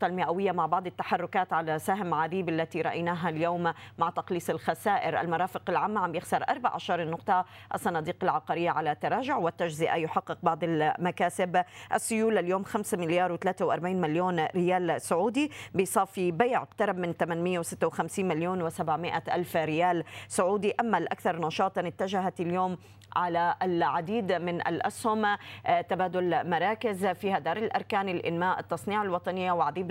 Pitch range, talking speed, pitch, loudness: 170-190 Hz, 125 wpm, 180 Hz, -29 LUFS